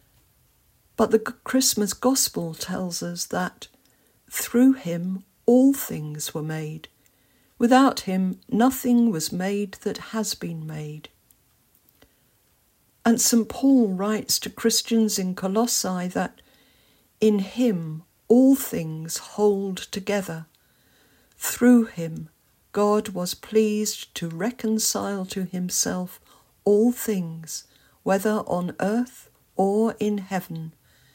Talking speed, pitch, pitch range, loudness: 105 wpm, 205 Hz, 175-230 Hz, -23 LUFS